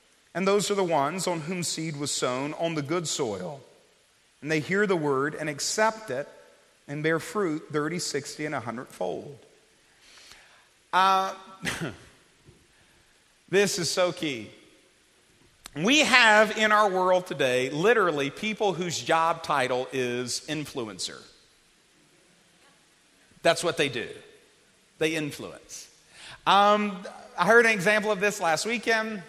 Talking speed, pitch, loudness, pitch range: 130 wpm, 180 Hz, -25 LUFS, 150-210 Hz